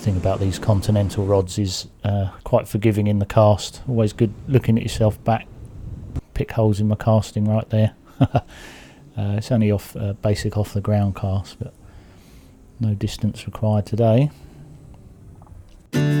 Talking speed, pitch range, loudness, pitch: 150 wpm, 100-110 Hz, -21 LUFS, 105 Hz